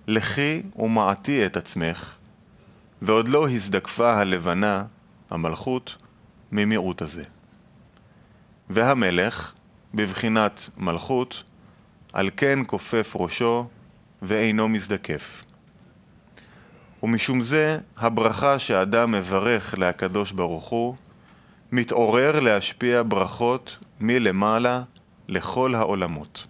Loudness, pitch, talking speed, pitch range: -23 LUFS, 110 Hz, 75 wpm, 95-120 Hz